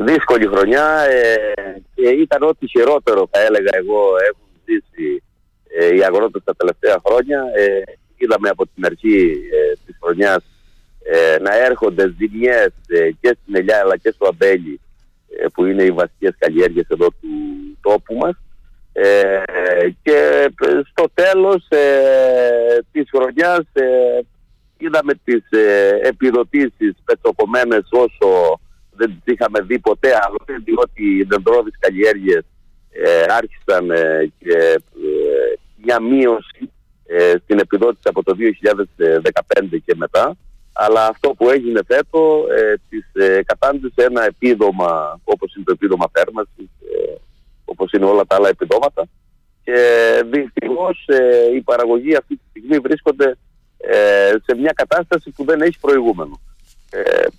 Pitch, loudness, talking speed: 360 Hz, -15 LUFS, 135 wpm